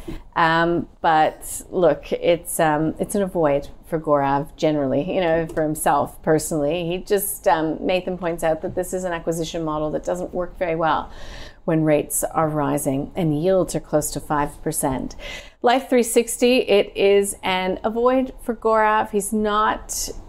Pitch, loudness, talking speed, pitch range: 170 Hz, -21 LUFS, 170 wpm, 155-200 Hz